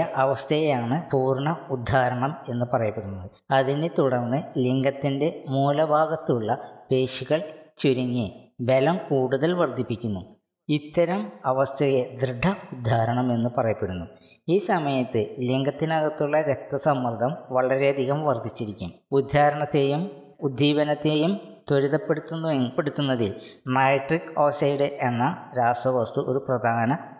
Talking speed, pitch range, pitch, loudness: 75 wpm, 125-150 Hz, 135 Hz, -24 LUFS